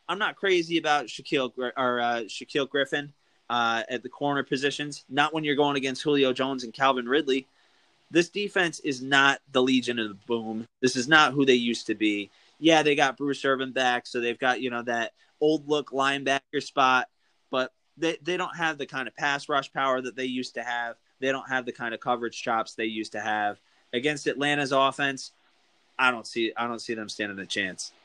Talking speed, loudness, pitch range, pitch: 210 wpm, -26 LUFS, 120-145 Hz, 130 Hz